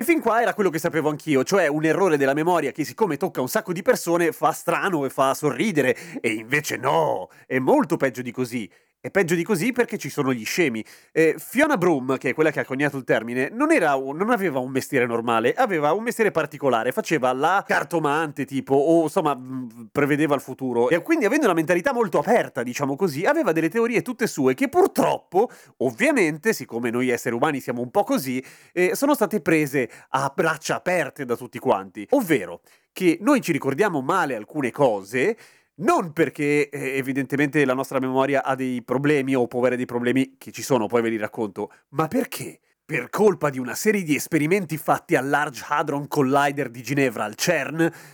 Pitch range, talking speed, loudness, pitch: 130-175 Hz, 195 wpm, -22 LUFS, 145 Hz